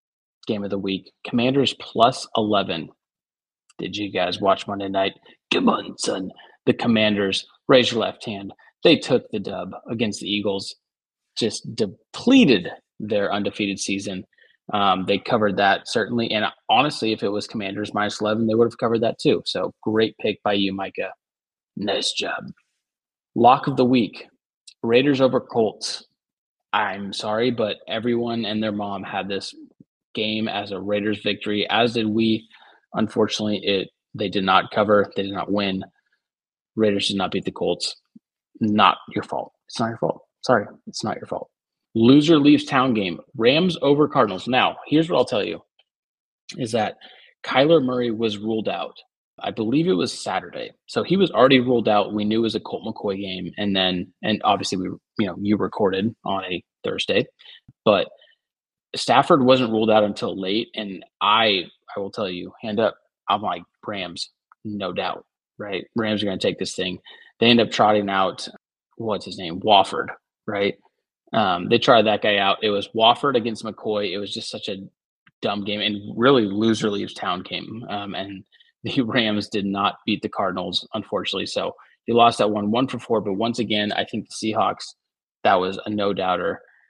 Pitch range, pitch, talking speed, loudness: 100-115 Hz, 105 Hz, 175 wpm, -22 LUFS